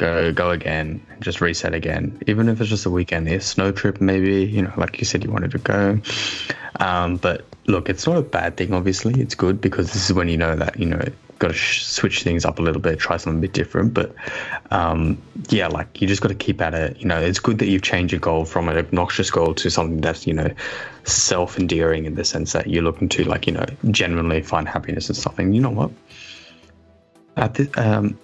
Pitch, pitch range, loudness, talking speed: 90 Hz, 80-100 Hz, -21 LUFS, 235 wpm